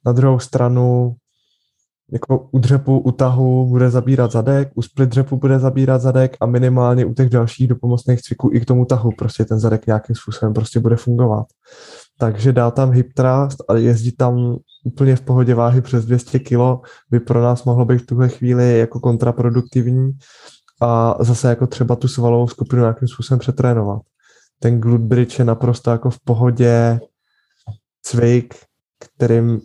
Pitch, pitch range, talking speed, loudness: 125 Hz, 120-130 Hz, 165 wpm, -16 LUFS